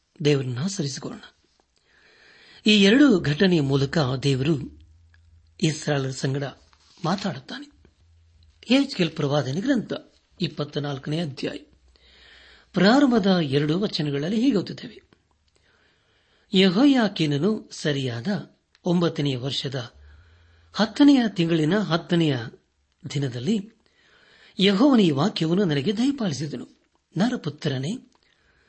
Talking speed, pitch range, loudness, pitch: 60 wpm, 135-205 Hz, -23 LUFS, 155 Hz